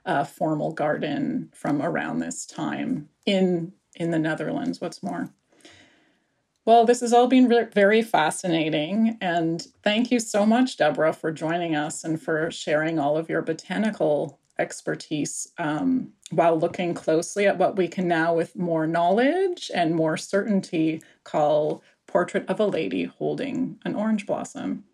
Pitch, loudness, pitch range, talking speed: 170 Hz, -24 LUFS, 160-210 Hz, 150 wpm